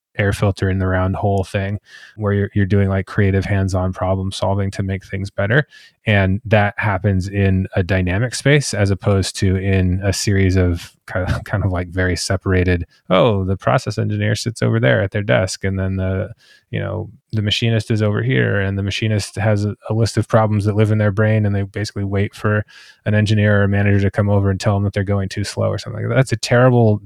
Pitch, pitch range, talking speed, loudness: 100 Hz, 95-110 Hz, 225 wpm, -18 LUFS